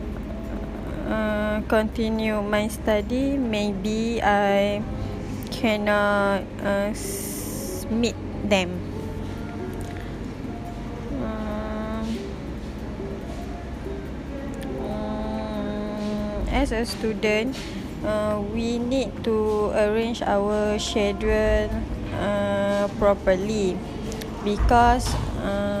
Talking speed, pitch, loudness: 60 wpm, 205 Hz, -25 LUFS